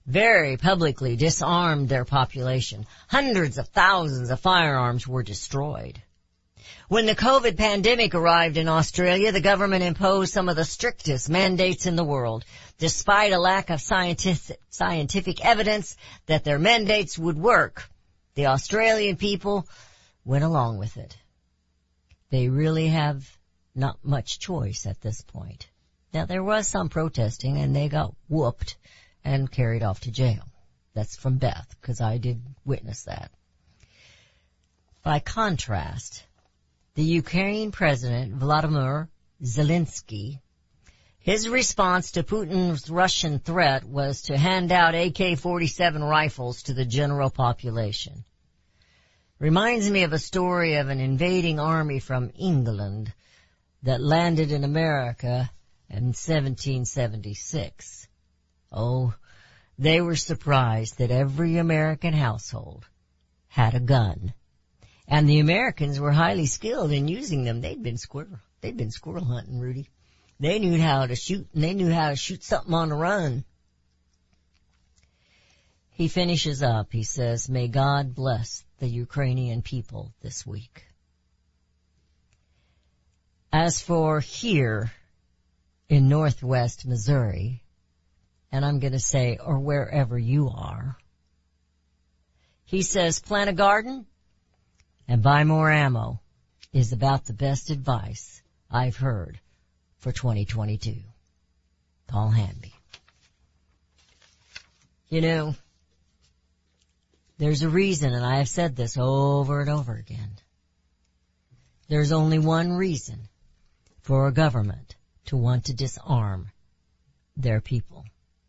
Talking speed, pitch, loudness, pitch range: 120 wpm, 130 Hz, -24 LUFS, 100-160 Hz